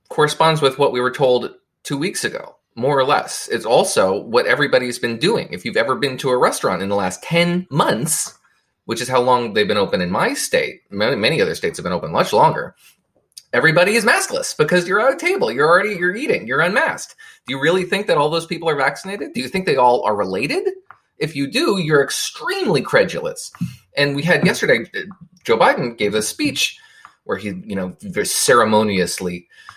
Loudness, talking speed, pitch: -18 LUFS, 200 wpm, 165 Hz